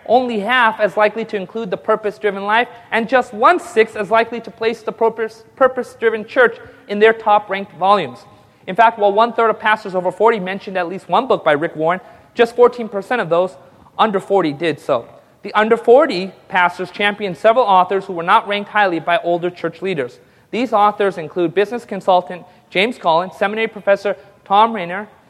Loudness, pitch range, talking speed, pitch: -16 LUFS, 185-225 Hz, 185 wpm, 205 Hz